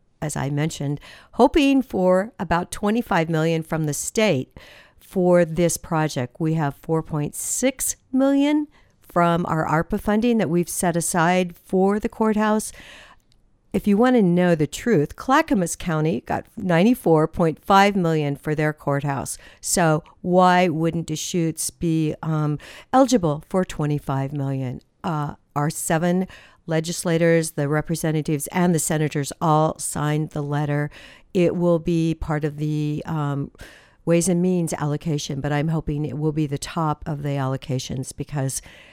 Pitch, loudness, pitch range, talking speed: 160 Hz, -22 LUFS, 150-180 Hz, 140 wpm